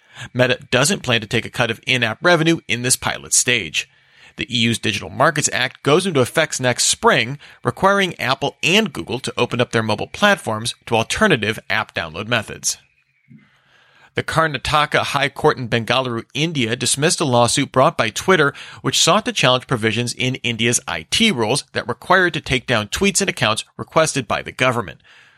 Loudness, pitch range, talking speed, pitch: -18 LUFS, 115-160 Hz, 175 wpm, 125 Hz